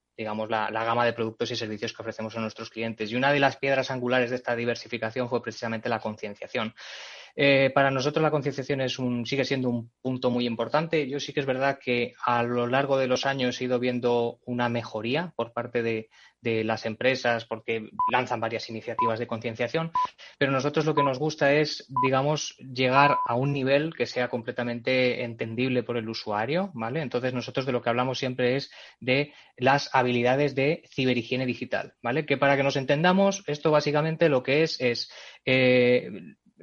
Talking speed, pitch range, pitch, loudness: 190 wpm, 120-140 Hz, 125 Hz, -26 LUFS